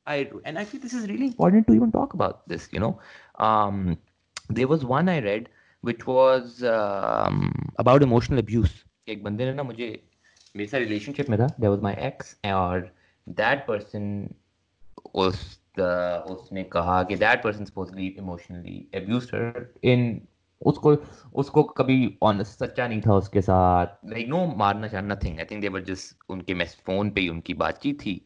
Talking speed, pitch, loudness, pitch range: 170 wpm, 105 Hz, -25 LUFS, 95-130 Hz